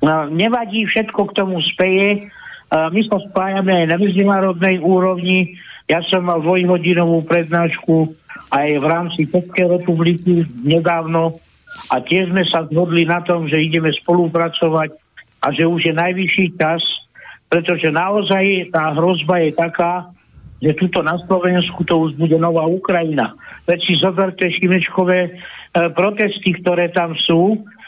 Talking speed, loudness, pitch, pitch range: 135 wpm, -16 LUFS, 175 Hz, 165-185 Hz